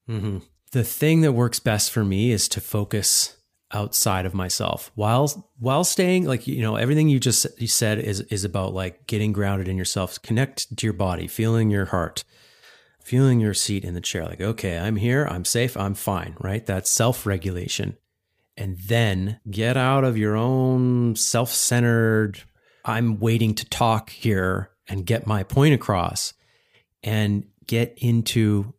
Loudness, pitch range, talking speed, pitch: -22 LUFS, 100-120 Hz, 165 wpm, 110 Hz